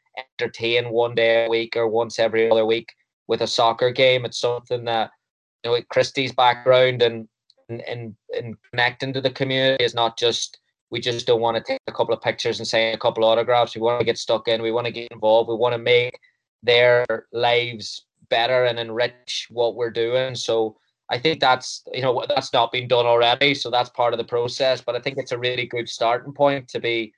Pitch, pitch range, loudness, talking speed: 120 Hz, 115-125 Hz, -21 LUFS, 220 wpm